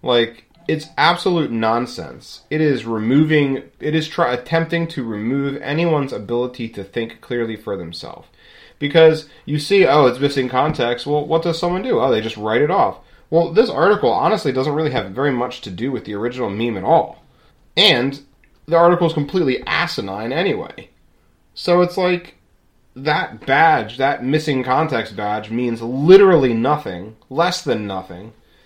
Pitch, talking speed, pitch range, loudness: 130 Hz, 160 wpm, 115-155 Hz, -18 LUFS